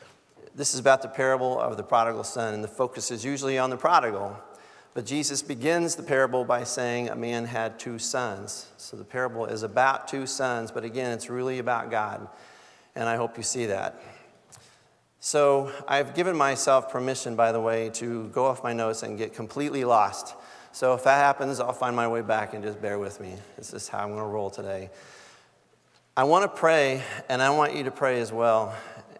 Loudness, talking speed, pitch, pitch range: -26 LUFS, 205 wpm, 125 Hz, 115-135 Hz